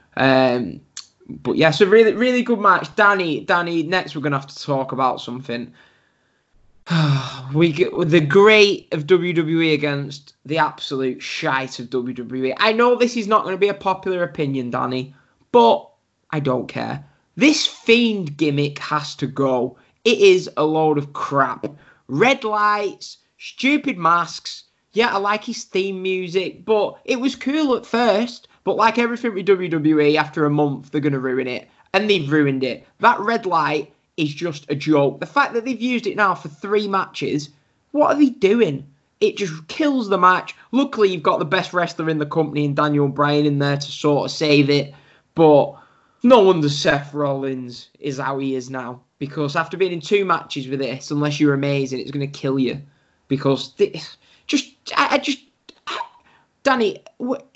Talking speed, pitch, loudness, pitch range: 175 wpm, 160 Hz, -19 LUFS, 140-210 Hz